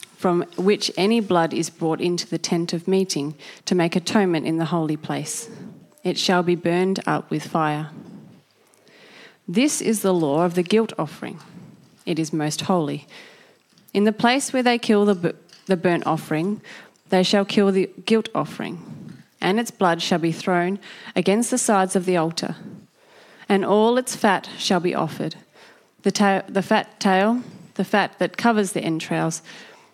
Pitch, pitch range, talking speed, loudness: 185 Hz, 170-210 Hz, 170 wpm, -22 LUFS